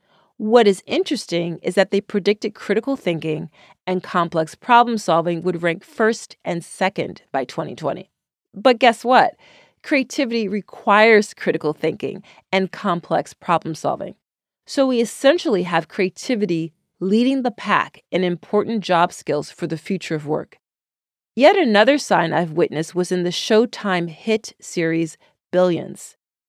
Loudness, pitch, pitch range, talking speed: -20 LUFS, 190 Hz, 170-220 Hz, 135 wpm